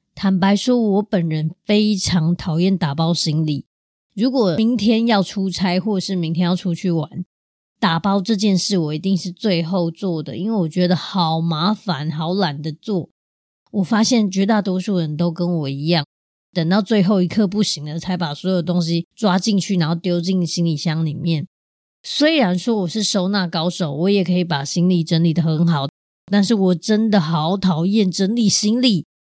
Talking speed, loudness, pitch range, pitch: 260 characters per minute, -19 LUFS, 165-205 Hz, 180 Hz